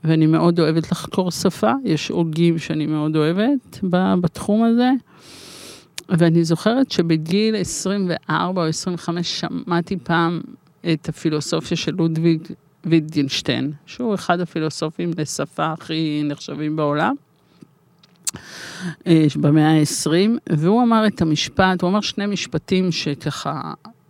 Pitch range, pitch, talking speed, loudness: 155-185 Hz, 170 Hz, 105 wpm, -20 LUFS